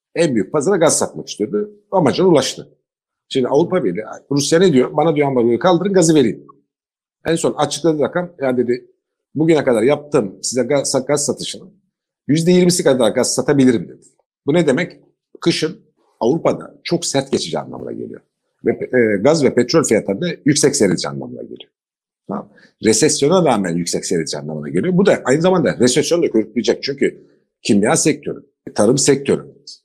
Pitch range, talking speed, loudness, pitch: 125-180 Hz, 155 wpm, -16 LUFS, 150 Hz